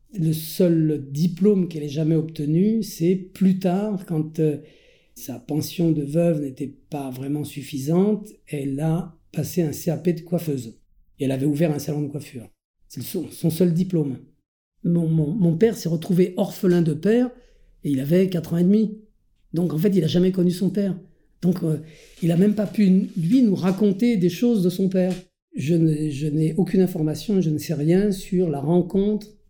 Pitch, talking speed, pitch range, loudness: 170 Hz, 190 wpm, 155-190 Hz, -22 LUFS